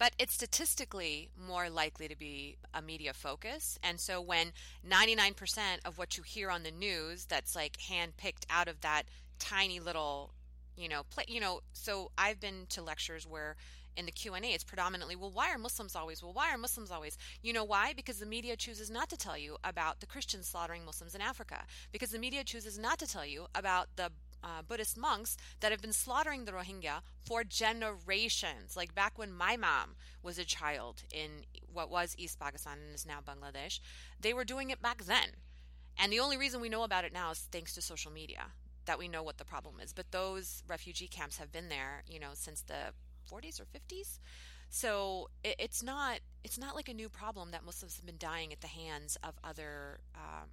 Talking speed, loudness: 210 wpm, -38 LUFS